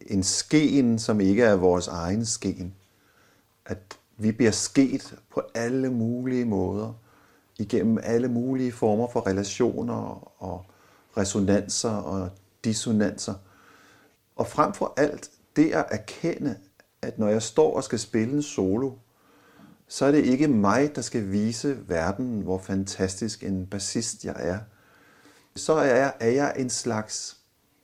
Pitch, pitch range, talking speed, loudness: 110 Hz, 95-120 Hz, 140 wpm, -25 LUFS